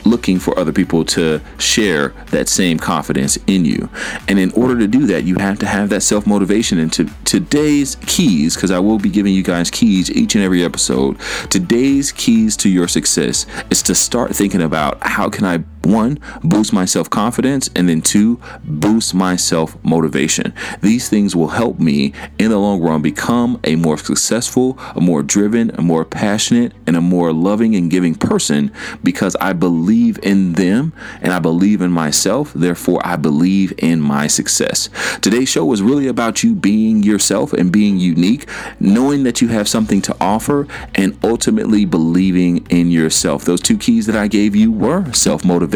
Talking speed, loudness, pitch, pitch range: 185 wpm, -14 LUFS, 100 Hz, 85-120 Hz